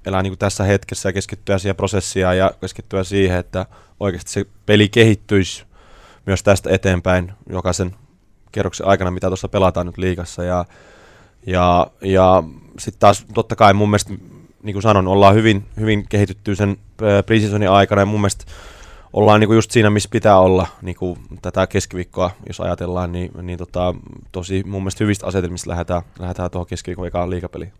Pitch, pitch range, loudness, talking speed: 95 Hz, 90-105 Hz, -17 LUFS, 165 wpm